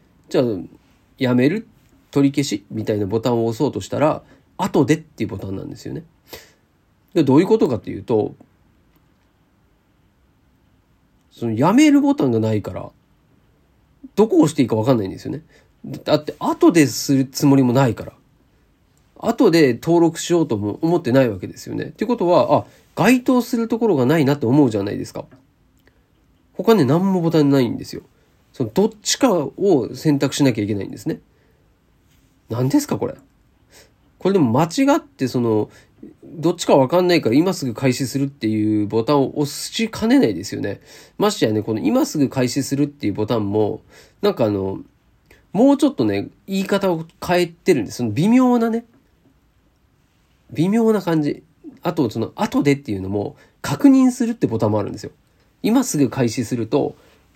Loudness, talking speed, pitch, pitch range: -19 LUFS, 340 characters per minute, 145 Hz, 115-195 Hz